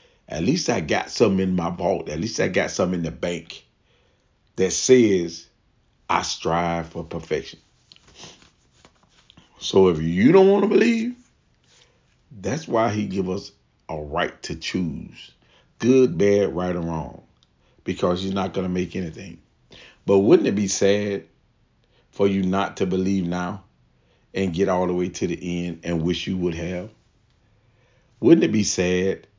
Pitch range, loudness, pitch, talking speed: 85-100 Hz, -22 LUFS, 95 Hz, 160 wpm